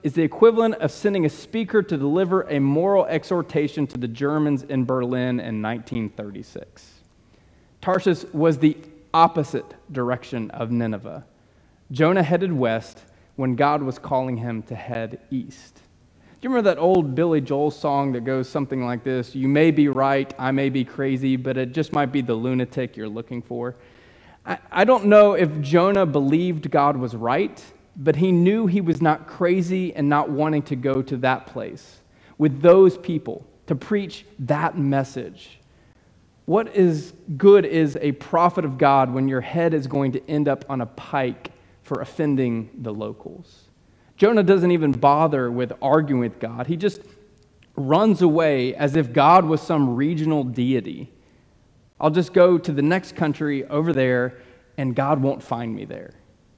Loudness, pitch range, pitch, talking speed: -21 LUFS, 125-165 Hz, 145 Hz, 165 wpm